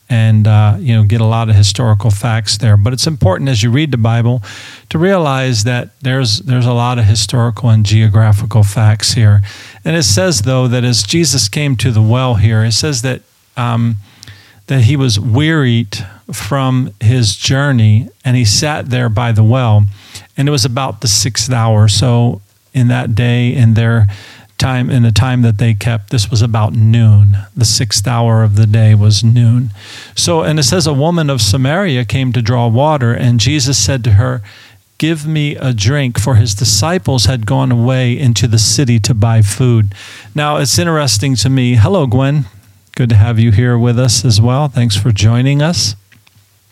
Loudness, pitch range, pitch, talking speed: -11 LUFS, 110-130 Hz, 120 Hz, 190 wpm